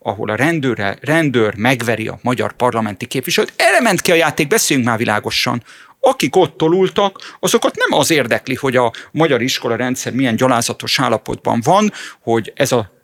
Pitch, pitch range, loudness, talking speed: 130 Hz, 115-165 Hz, -15 LUFS, 160 wpm